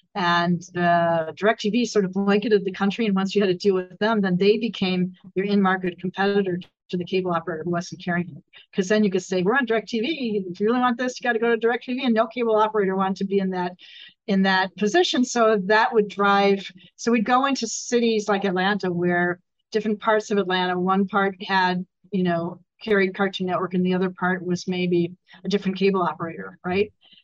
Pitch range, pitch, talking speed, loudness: 180-215 Hz, 195 Hz, 210 wpm, -22 LUFS